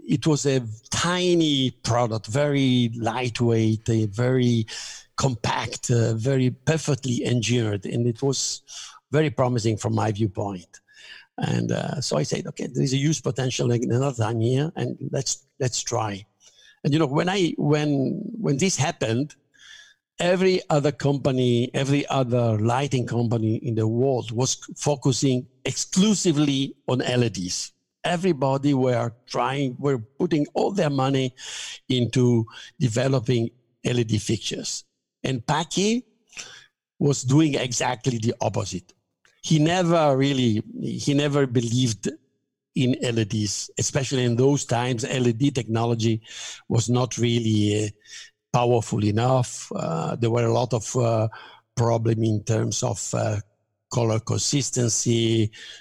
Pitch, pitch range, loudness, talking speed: 125 Hz, 115-140 Hz, -23 LUFS, 125 wpm